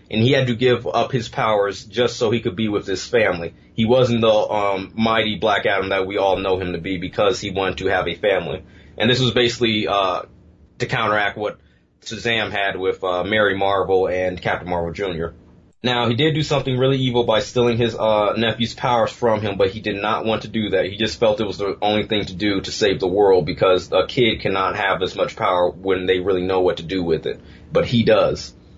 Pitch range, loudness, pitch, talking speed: 95-115 Hz, -19 LUFS, 105 Hz, 235 wpm